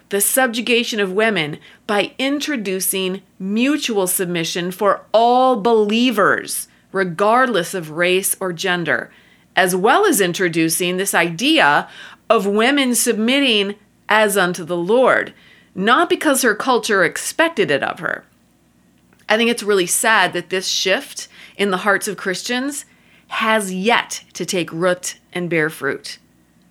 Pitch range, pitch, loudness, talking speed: 180-235 Hz, 200 Hz, -17 LUFS, 130 wpm